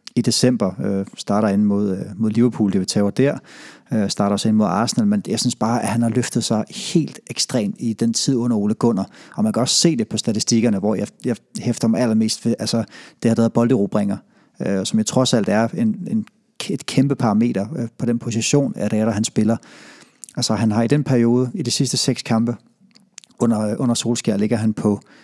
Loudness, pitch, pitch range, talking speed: -19 LUFS, 120 Hz, 110-135 Hz, 230 wpm